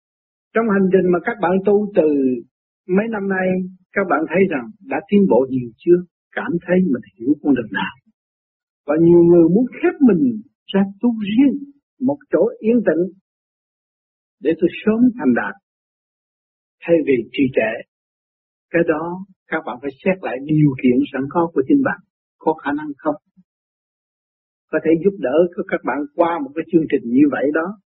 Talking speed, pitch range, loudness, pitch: 175 wpm, 160-220 Hz, -18 LUFS, 185 Hz